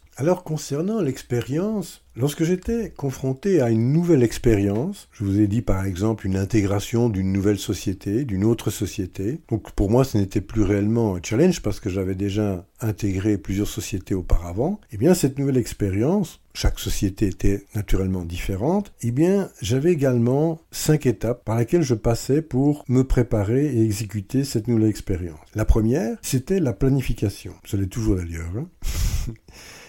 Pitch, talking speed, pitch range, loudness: 115 Hz, 160 wpm, 100-140 Hz, -23 LUFS